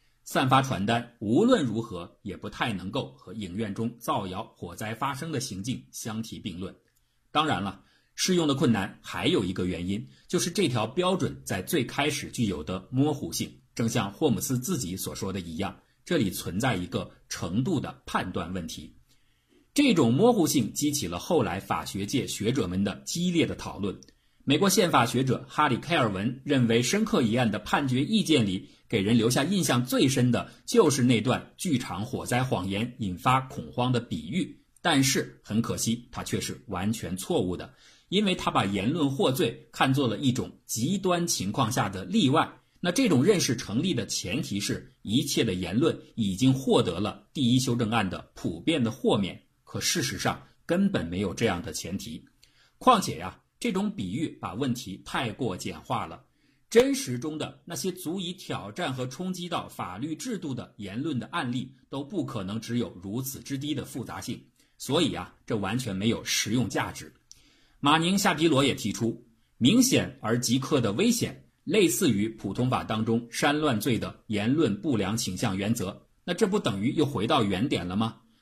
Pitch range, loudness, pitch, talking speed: 110-155 Hz, -27 LUFS, 125 Hz, 265 characters per minute